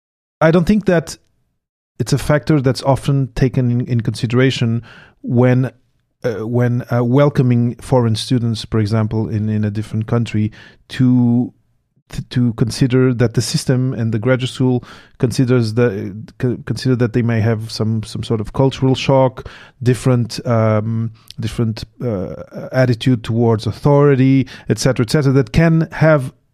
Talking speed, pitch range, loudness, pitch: 145 wpm, 115-135 Hz, -16 LUFS, 125 Hz